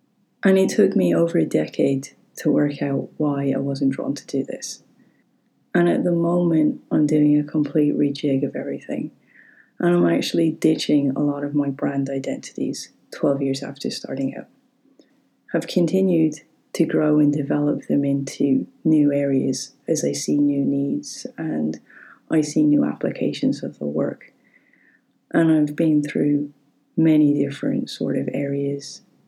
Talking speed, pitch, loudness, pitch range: 155 wpm, 145 Hz, -21 LUFS, 135-155 Hz